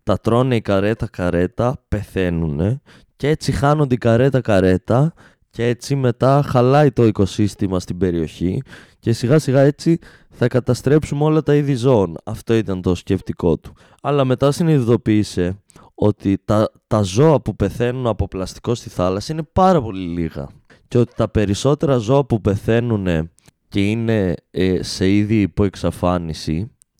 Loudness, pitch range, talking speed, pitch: -18 LUFS, 95-130 Hz, 145 wpm, 110 Hz